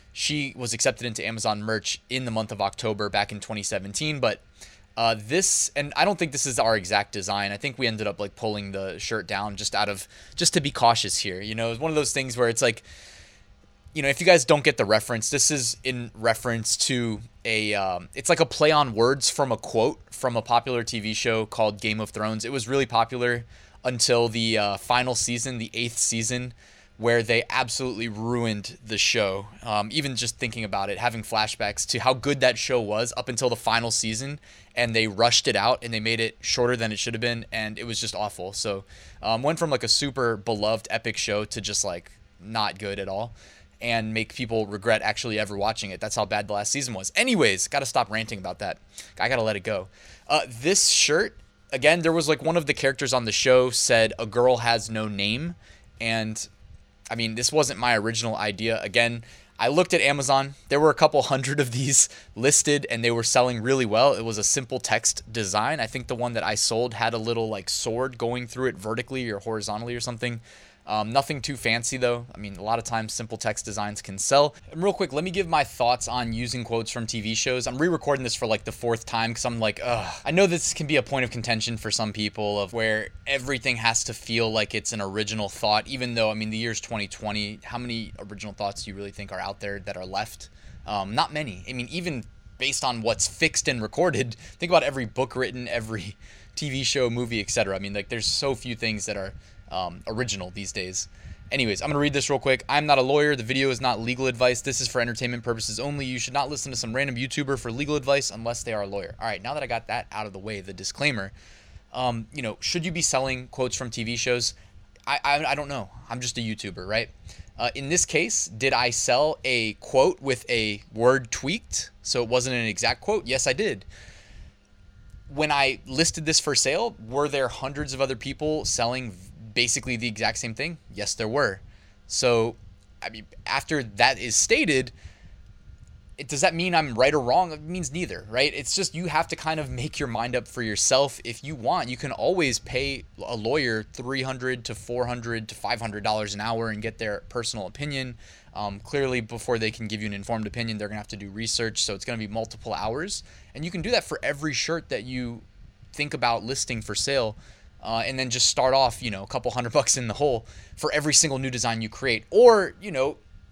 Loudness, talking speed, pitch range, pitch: -25 LUFS, 225 wpm, 105-130 Hz, 115 Hz